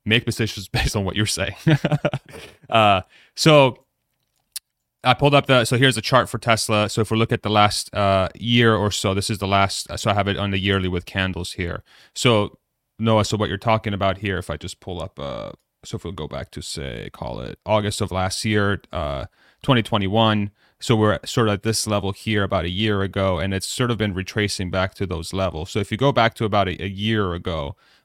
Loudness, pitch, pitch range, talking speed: -21 LUFS, 105 Hz, 95-115 Hz, 230 wpm